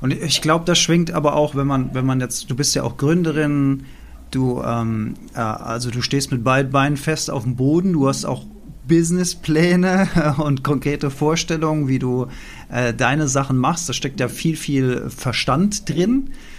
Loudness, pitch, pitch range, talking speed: -19 LUFS, 145 Hz, 130-160 Hz, 175 wpm